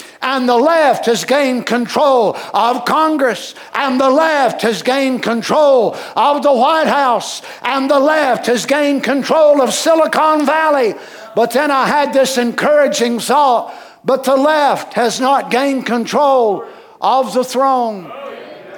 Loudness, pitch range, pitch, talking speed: -13 LUFS, 240-290 Hz, 265 Hz, 140 wpm